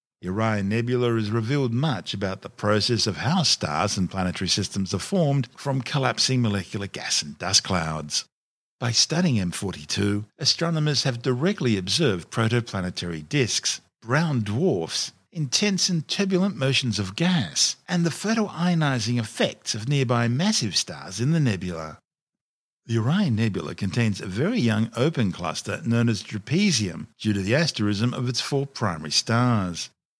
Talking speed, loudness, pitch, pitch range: 145 wpm, -24 LUFS, 120 Hz, 105-145 Hz